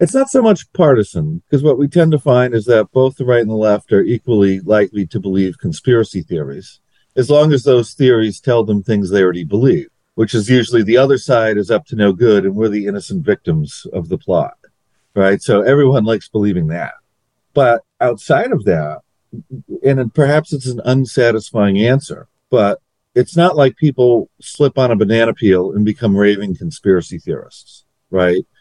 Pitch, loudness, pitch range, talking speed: 120 Hz, -14 LUFS, 105-140 Hz, 185 wpm